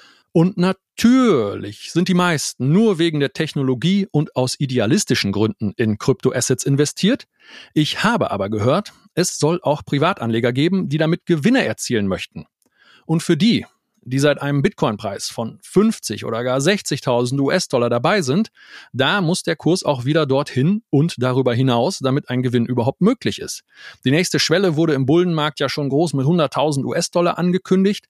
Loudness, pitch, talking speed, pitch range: -18 LUFS, 150 Hz, 160 wpm, 130-180 Hz